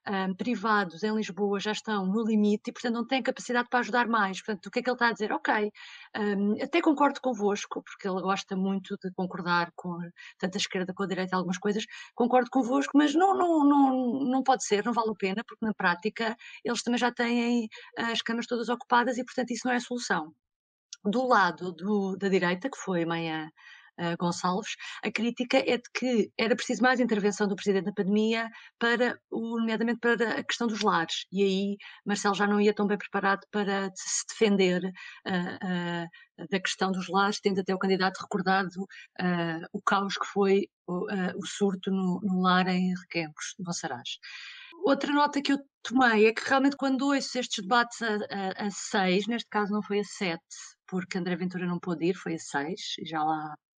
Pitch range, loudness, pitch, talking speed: 190-240 Hz, -28 LUFS, 205 Hz, 200 wpm